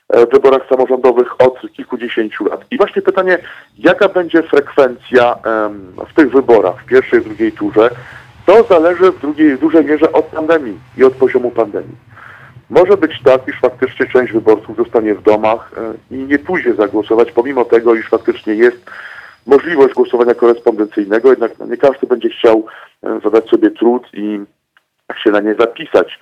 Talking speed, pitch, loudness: 155 wpm, 150 Hz, -12 LUFS